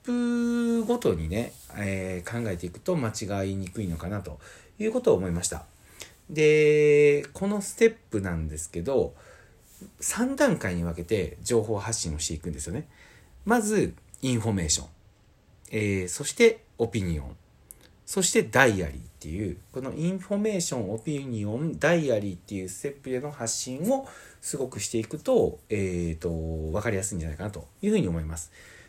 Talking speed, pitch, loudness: 355 characters per minute, 110 Hz, -27 LUFS